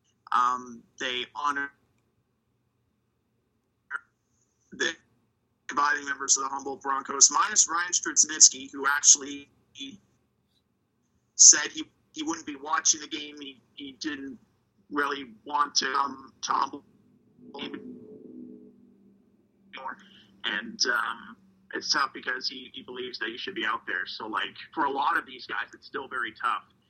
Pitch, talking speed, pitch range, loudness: 140 Hz, 125 wpm, 120-155 Hz, -24 LUFS